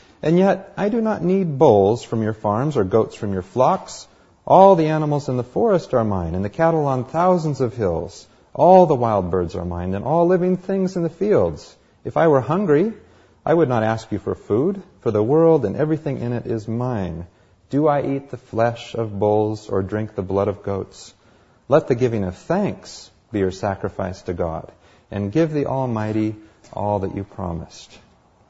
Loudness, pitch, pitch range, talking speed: -20 LUFS, 115 Hz, 100-155 Hz, 200 wpm